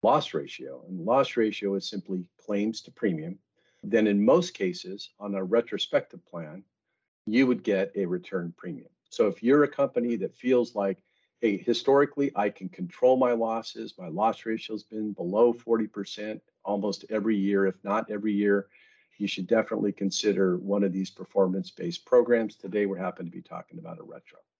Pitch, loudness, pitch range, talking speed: 105 Hz, -27 LUFS, 100-120 Hz, 175 wpm